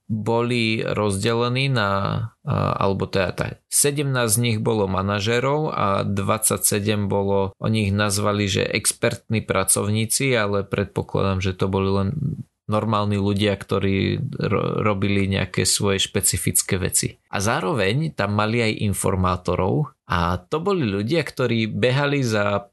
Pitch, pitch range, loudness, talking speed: 105 Hz, 100-120 Hz, -21 LUFS, 125 wpm